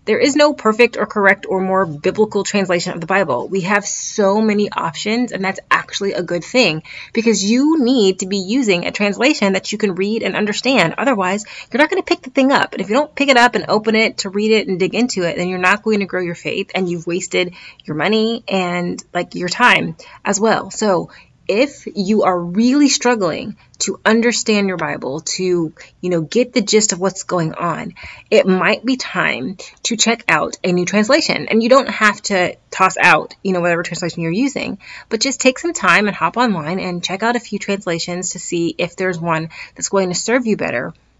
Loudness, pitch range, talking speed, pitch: -16 LUFS, 180-230 Hz, 220 wpm, 200 Hz